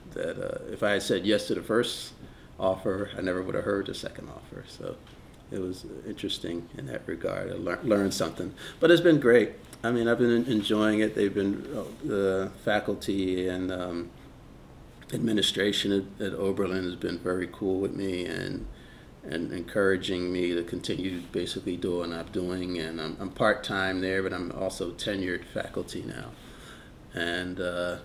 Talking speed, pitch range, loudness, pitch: 170 wpm, 90-105 Hz, -29 LUFS, 95 Hz